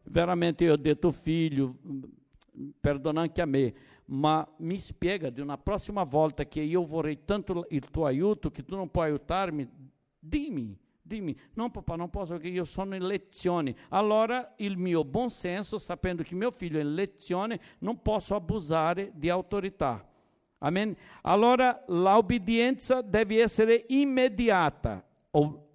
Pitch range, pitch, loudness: 155-210 Hz, 180 Hz, -29 LUFS